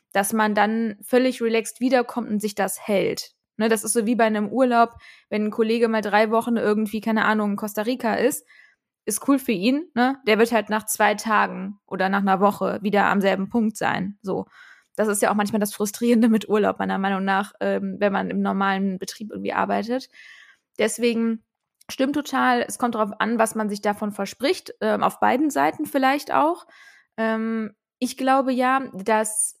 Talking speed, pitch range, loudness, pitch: 185 wpm, 205-240 Hz, -22 LUFS, 220 Hz